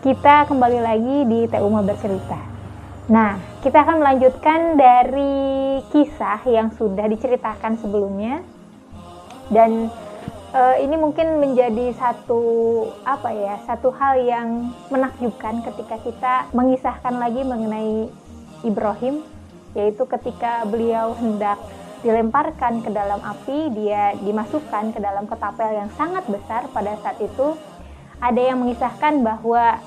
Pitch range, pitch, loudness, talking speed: 220-260 Hz, 235 Hz, -19 LUFS, 115 wpm